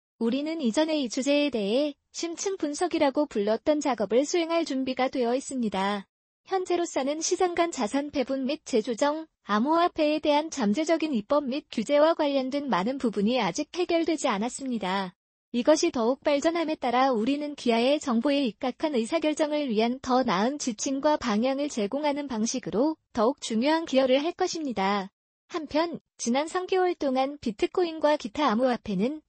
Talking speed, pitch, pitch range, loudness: 345 characters per minute, 280 Hz, 245-310 Hz, -27 LUFS